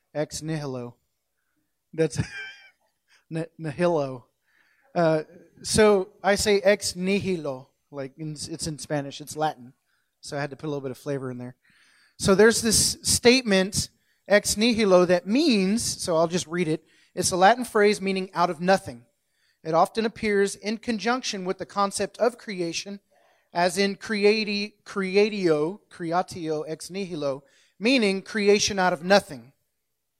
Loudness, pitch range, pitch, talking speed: -24 LUFS, 150-205 Hz, 180 Hz, 145 wpm